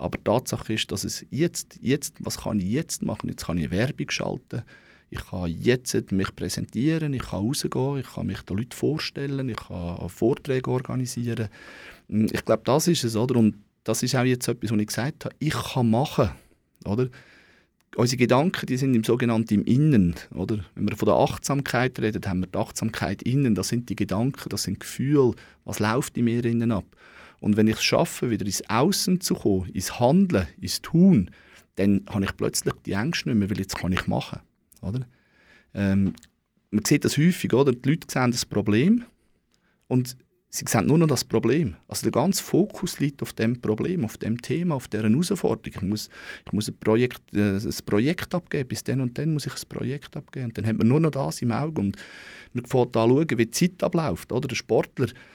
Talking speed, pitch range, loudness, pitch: 205 wpm, 105-140 Hz, -25 LUFS, 120 Hz